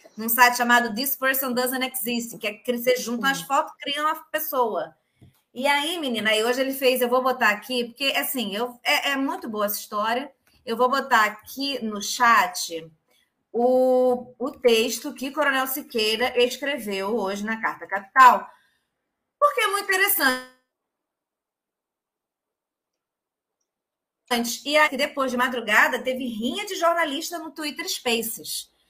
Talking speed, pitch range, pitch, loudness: 145 wpm, 230-275 Hz, 250 Hz, -22 LUFS